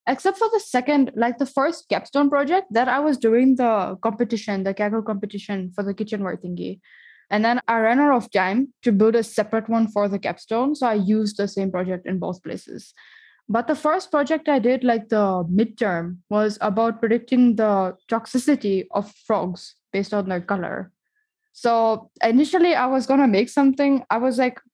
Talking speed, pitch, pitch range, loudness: 185 wpm, 230 Hz, 205-270 Hz, -21 LUFS